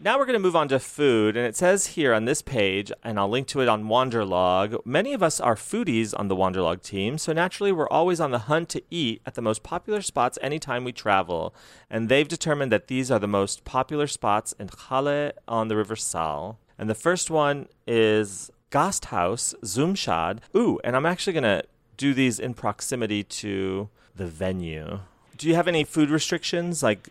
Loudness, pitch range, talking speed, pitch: -25 LUFS, 105-155 Hz, 200 wpm, 125 Hz